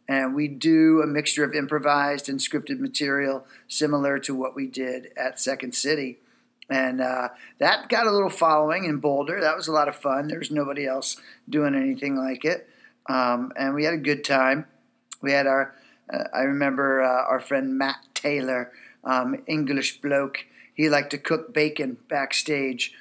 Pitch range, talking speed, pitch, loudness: 135-150 Hz, 175 wpm, 140 Hz, -24 LUFS